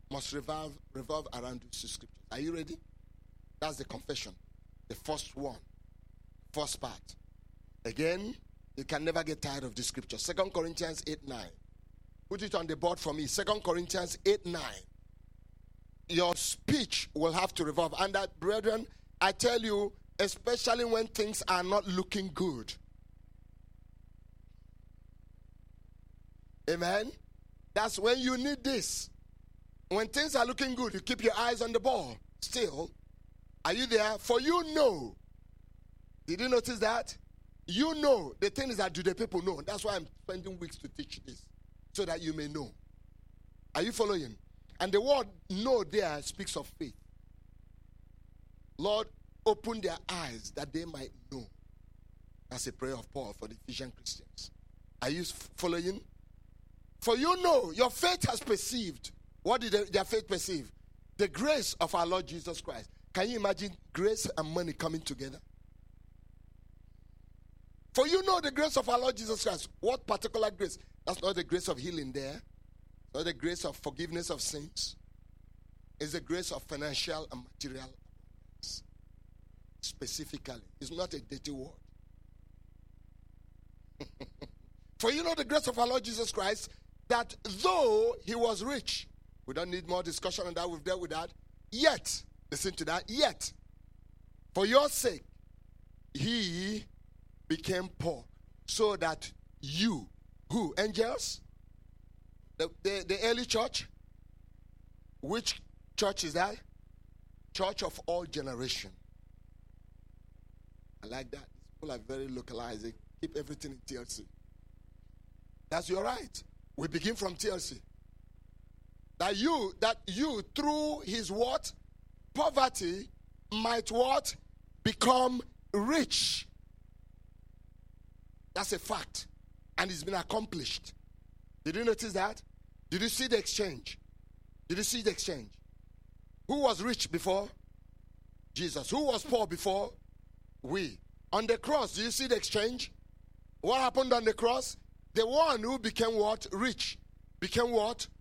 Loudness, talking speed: -34 LUFS, 140 wpm